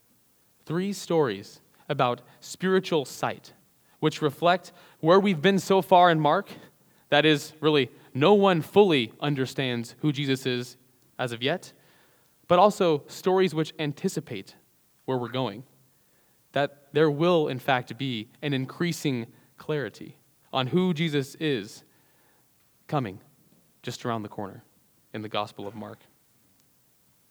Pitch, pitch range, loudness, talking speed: 150 Hz, 125-175 Hz, -25 LUFS, 125 wpm